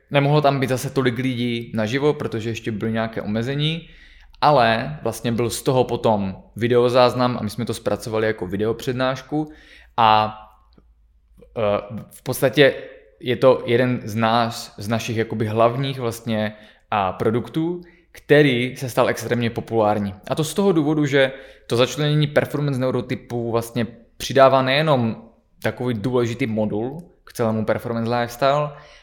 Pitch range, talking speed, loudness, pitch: 110-135 Hz, 135 wpm, -21 LUFS, 120 Hz